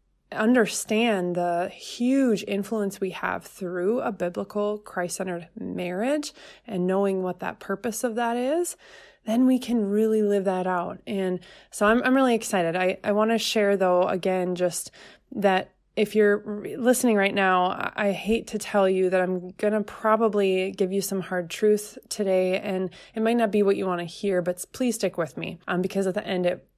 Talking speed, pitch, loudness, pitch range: 190 wpm, 200 Hz, -25 LUFS, 185-220 Hz